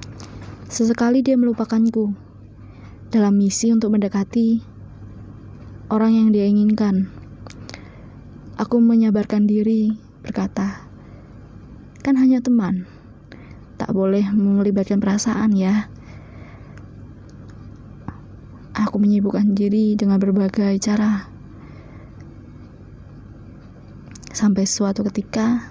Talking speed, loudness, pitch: 75 wpm, -19 LUFS, 200 Hz